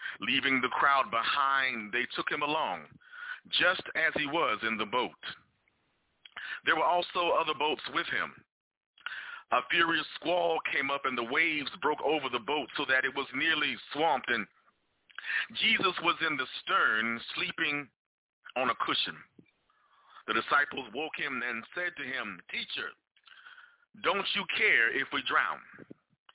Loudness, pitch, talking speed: -29 LUFS, 165 Hz, 150 wpm